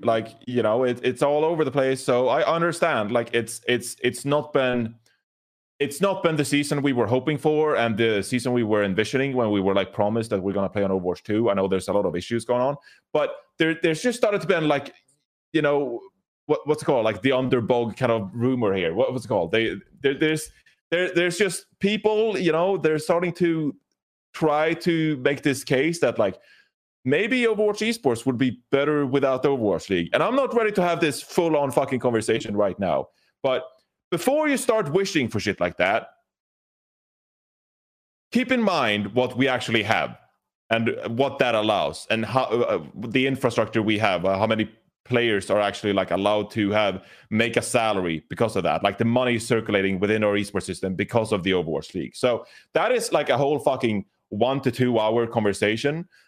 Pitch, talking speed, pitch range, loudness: 130 Hz, 205 wpm, 110-155 Hz, -23 LUFS